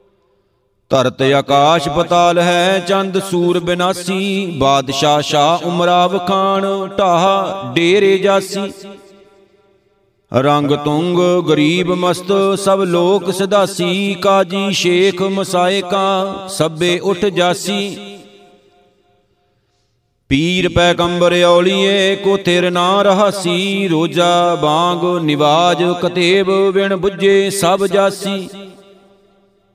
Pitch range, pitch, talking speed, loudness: 175-195 Hz, 180 Hz, 85 wpm, -14 LUFS